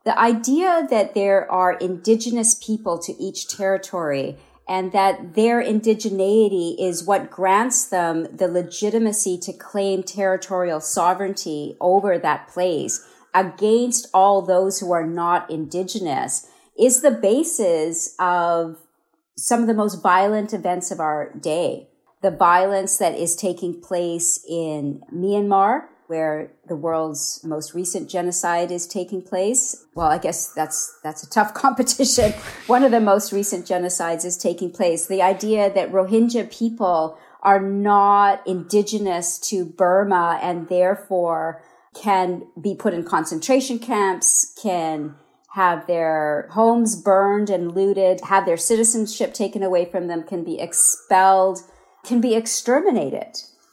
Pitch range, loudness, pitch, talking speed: 175-210 Hz, -20 LUFS, 190 Hz, 135 wpm